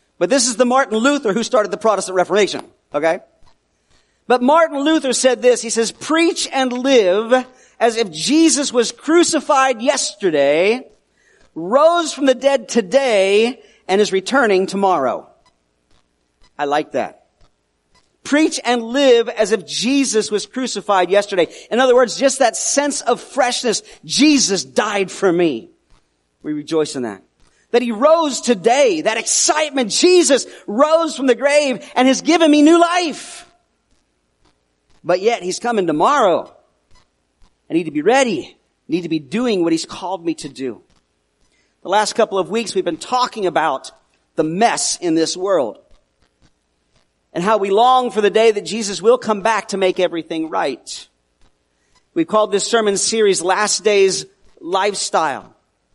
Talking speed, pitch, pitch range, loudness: 150 wpm, 220 Hz, 180-265 Hz, -16 LUFS